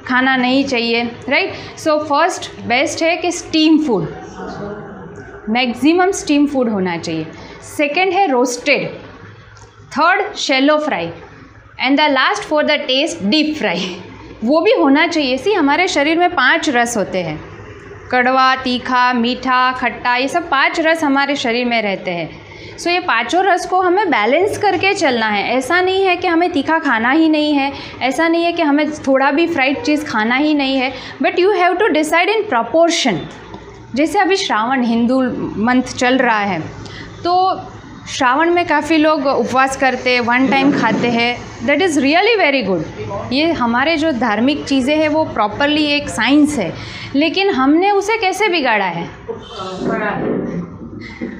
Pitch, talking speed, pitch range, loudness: 280 Hz, 160 wpm, 245-330 Hz, -15 LUFS